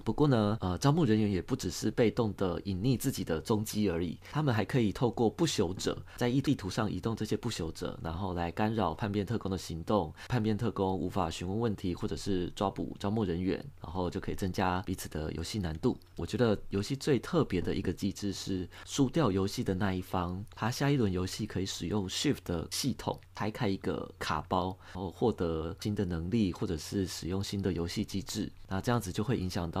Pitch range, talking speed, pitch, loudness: 90-110 Hz, 330 characters per minute, 95 Hz, -33 LUFS